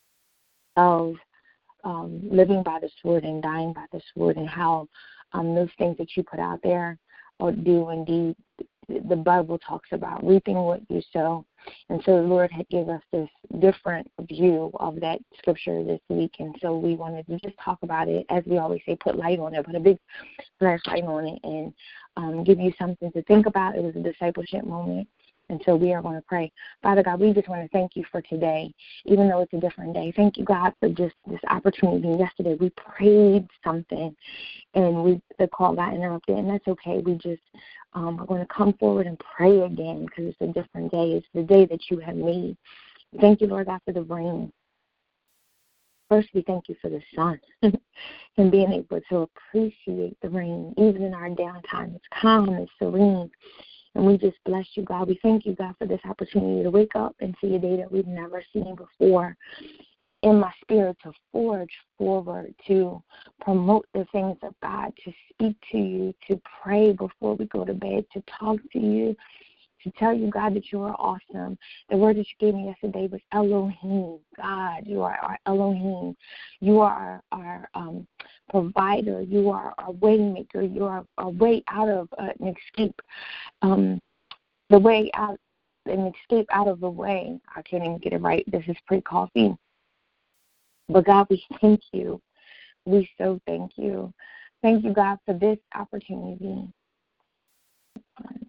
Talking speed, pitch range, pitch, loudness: 185 wpm, 170-205 Hz, 185 Hz, -24 LUFS